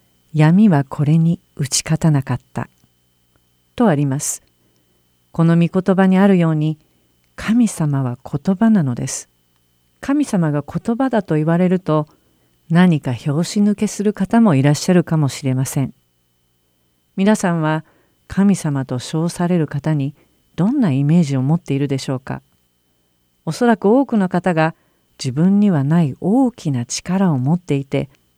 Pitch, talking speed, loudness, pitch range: 155 Hz, 275 characters per minute, -17 LUFS, 125-185 Hz